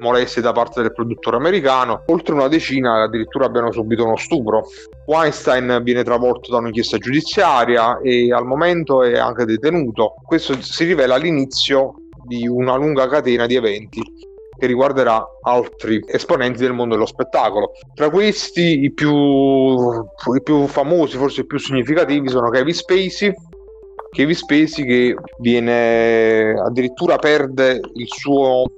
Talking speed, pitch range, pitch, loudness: 140 wpm, 120-150 Hz, 130 Hz, -16 LUFS